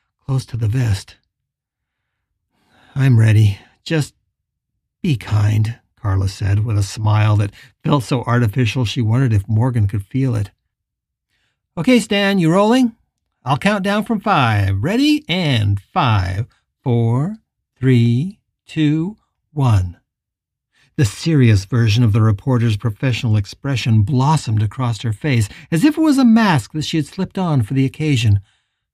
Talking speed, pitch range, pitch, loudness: 140 wpm, 110-155 Hz, 125 Hz, -17 LUFS